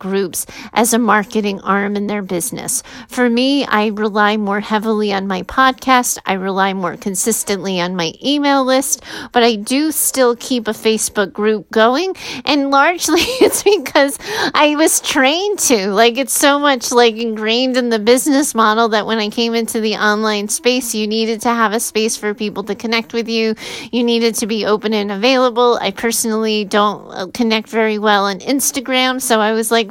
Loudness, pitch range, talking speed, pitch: -15 LUFS, 210-255 Hz, 185 wpm, 230 Hz